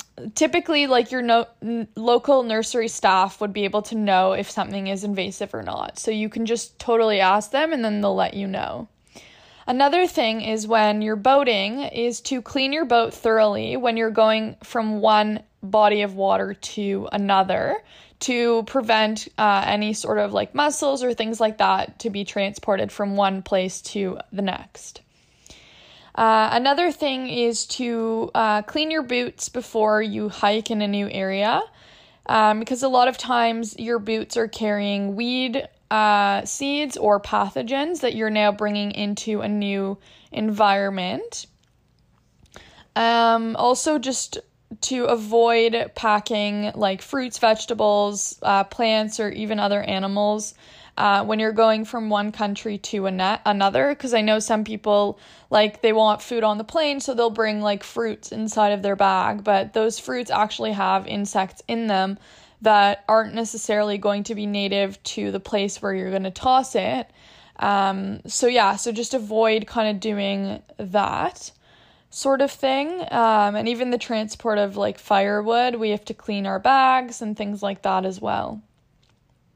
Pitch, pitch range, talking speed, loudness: 215 Hz, 205-235 Hz, 165 wpm, -22 LUFS